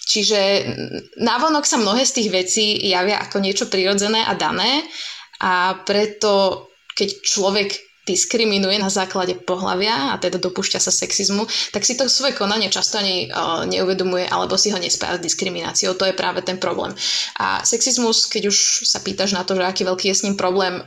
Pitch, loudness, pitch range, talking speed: 200 Hz, -18 LUFS, 185-215 Hz, 175 wpm